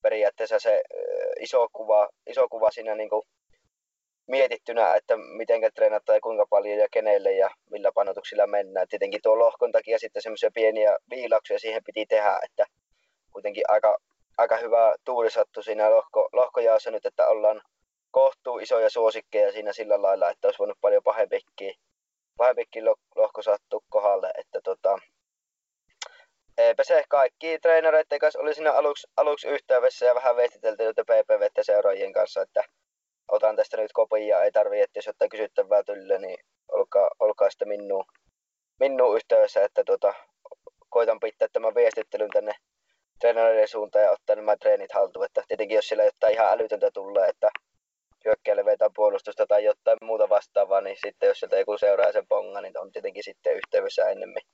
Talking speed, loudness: 155 wpm, -24 LUFS